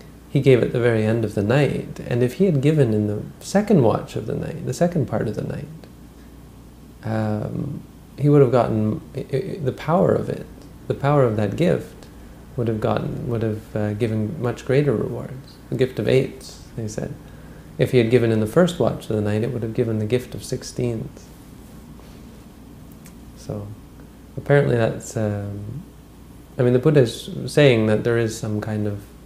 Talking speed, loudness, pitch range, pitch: 195 wpm, -21 LUFS, 105-135 Hz, 120 Hz